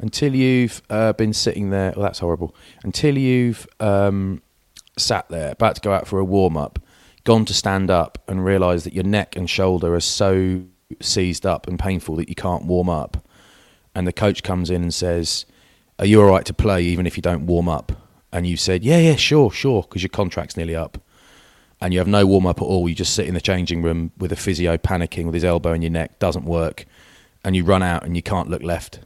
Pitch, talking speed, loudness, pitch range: 90 Hz, 230 wpm, -19 LUFS, 85-100 Hz